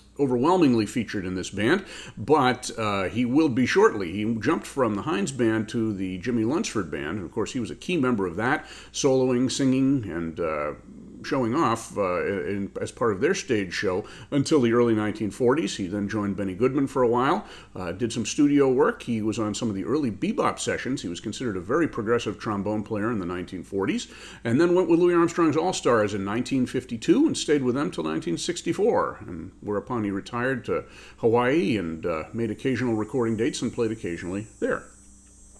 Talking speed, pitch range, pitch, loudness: 190 wpm, 100-130 Hz, 115 Hz, -25 LUFS